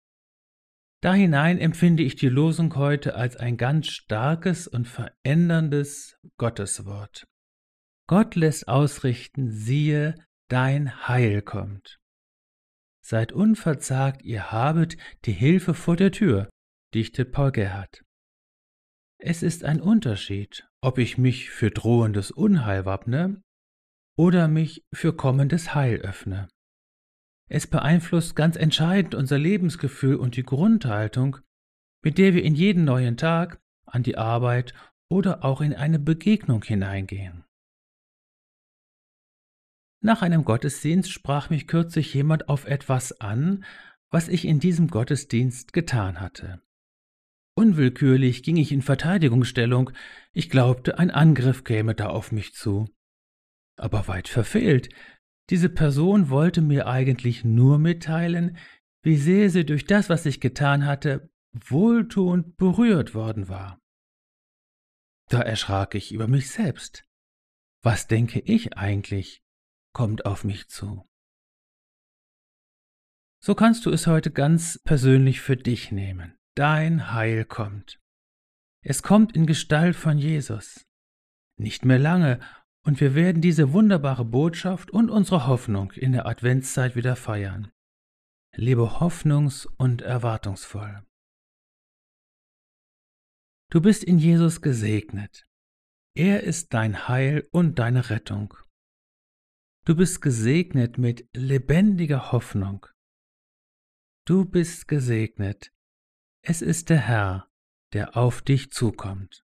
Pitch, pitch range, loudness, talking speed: 135 Hz, 110-165 Hz, -23 LUFS, 115 wpm